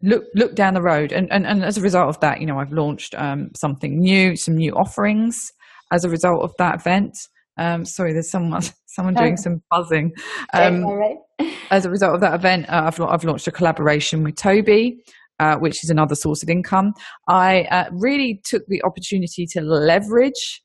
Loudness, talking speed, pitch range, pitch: -19 LUFS, 195 wpm, 165-200 Hz, 180 Hz